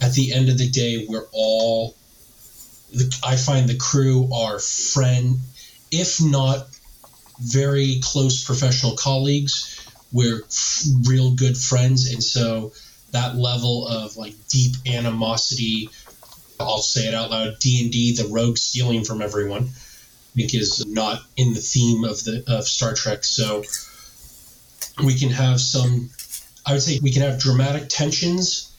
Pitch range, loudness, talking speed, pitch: 115-135 Hz, -20 LUFS, 150 wpm, 125 Hz